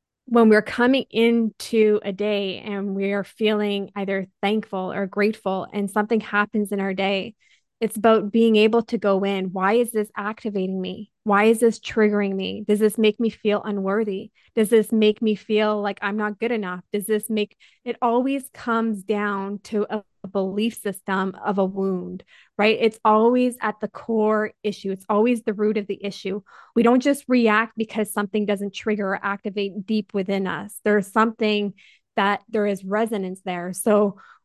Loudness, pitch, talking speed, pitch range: -22 LUFS, 210 Hz, 180 wpm, 200-220 Hz